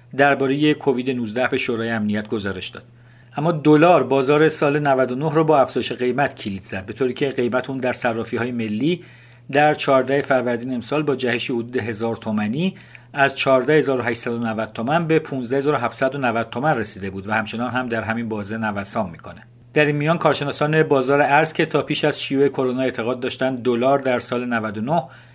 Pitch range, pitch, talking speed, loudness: 115-140 Hz, 130 Hz, 170 wpm, -20 LUFS